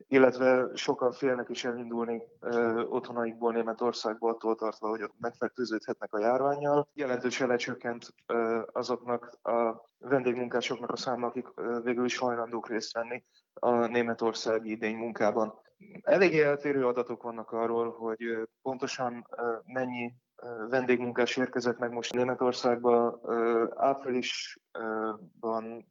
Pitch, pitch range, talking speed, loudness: 120 Hz, 115-125 Hz, 120 wpm, -31 LUFS